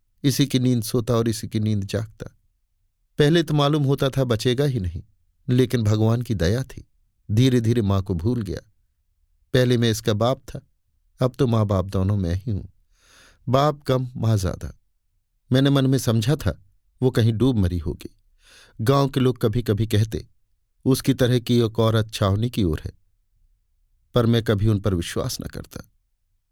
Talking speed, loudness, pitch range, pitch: 175 wpm, -22 LUFS, 95-125 Hz, 110 Hz